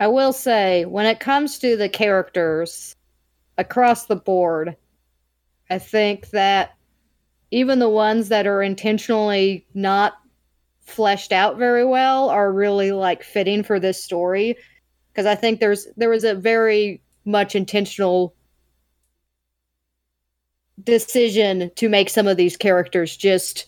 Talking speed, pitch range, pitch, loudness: 130 wpm, 175-220 Hz, 200 Hz, -19 LUFS